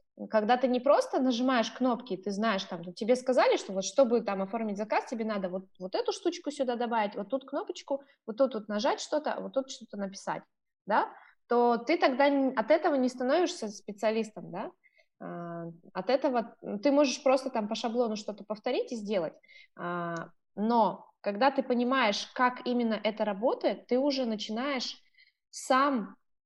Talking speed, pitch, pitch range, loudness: 160 wpm, 245 Hz, 210-275 Hz, -30 LUFS